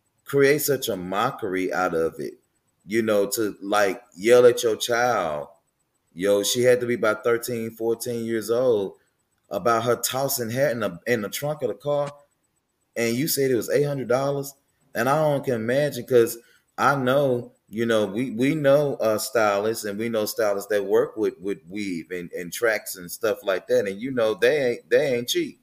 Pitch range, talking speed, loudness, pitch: 115-145 Hz, 195 wpm, -23 LUFS, 125 Hz